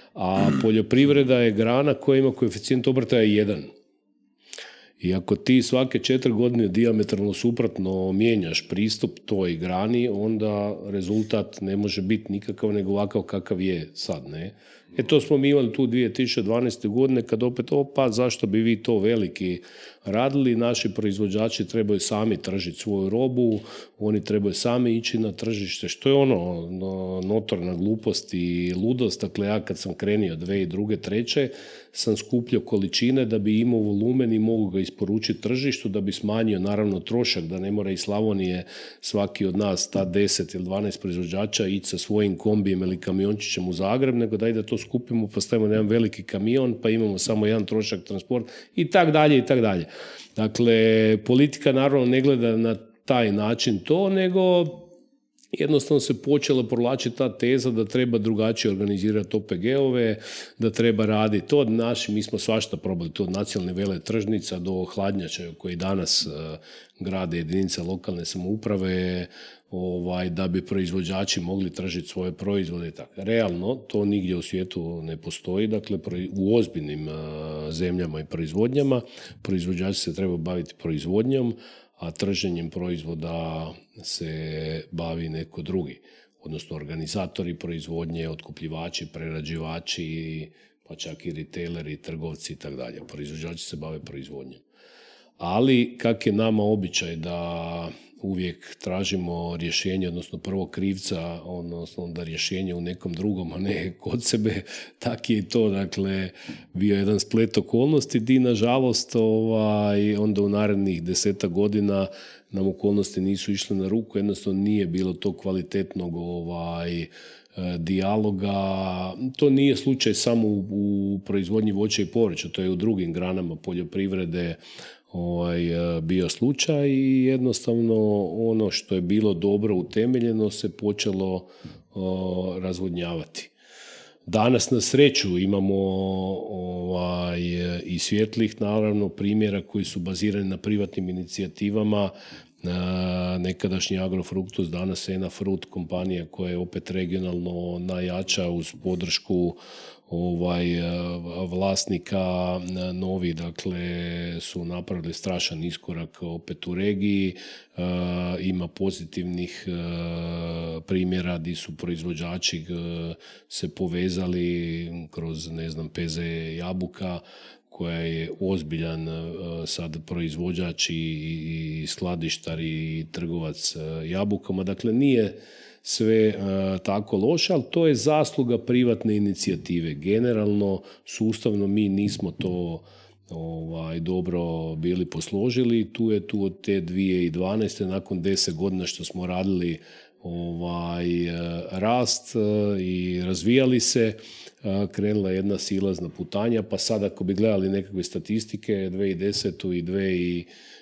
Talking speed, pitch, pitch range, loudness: 130 wpm, 95 Hz, 90-110 Hz, -25 LUFS